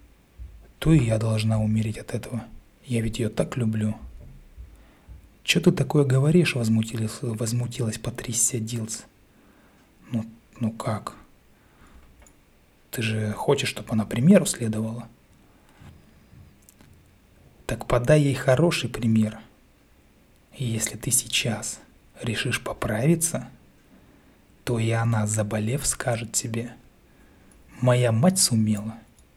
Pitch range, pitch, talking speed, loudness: 105-120 Hz, 115 Hz, 100 wpm, -24 LUFS